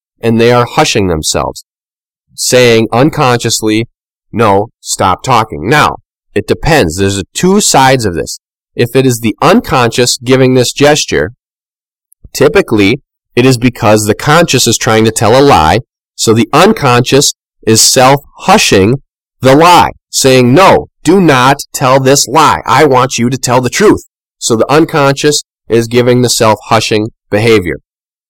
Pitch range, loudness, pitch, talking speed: 110-135 Hz, -8 LUFS, 120 Hz, 150 wpm